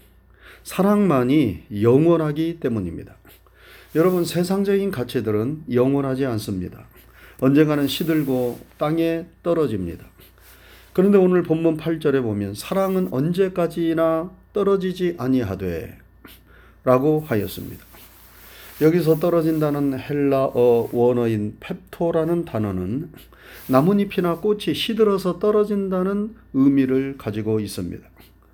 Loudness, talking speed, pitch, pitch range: -21 LUFS, 265 characters per minute, 150 Hz, 115-175 Hz